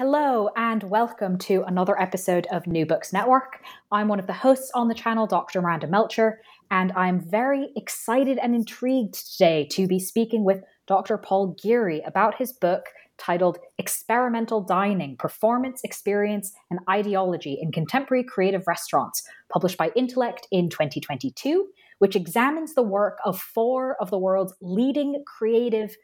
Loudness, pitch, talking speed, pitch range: -24 LUFS, 205 Hz, 150 wpm, 185-235 Hz